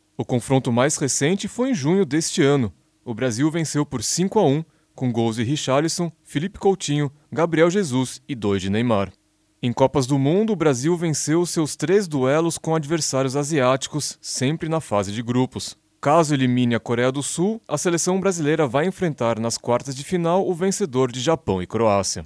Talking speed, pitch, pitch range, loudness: 180 wpm, 145 Hz, 125-165 Hz, -21 LUFS